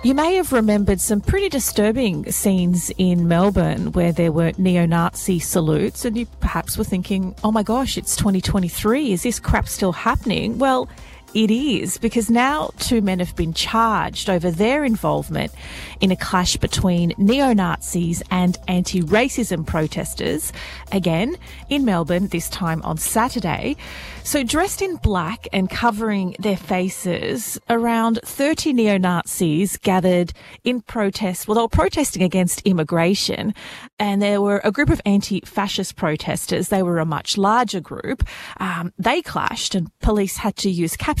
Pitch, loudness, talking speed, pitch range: 200 Hz, -20 LUFS, 155 wpm, 180-230 Hz